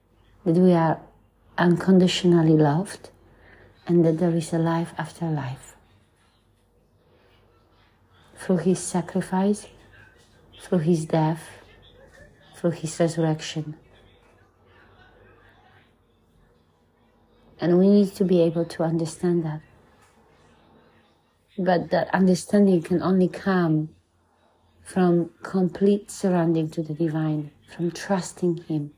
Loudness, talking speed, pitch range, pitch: -23 LUFS, 95 wpm, 110-175 Hz, 165 Hz